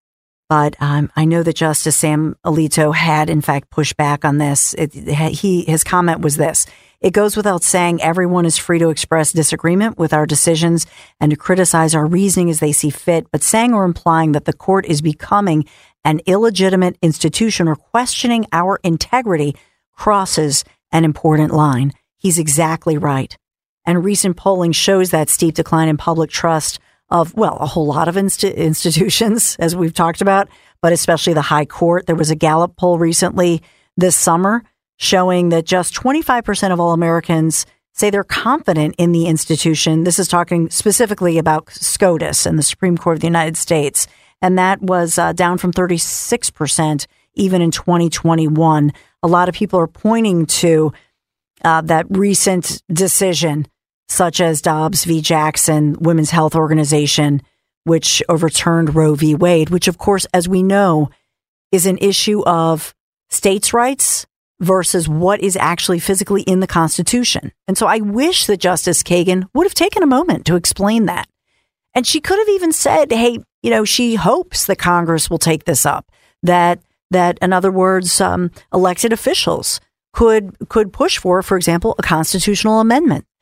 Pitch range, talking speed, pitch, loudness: 160-190 Hz, 165 wpm, 170 Hz, -14 LUFS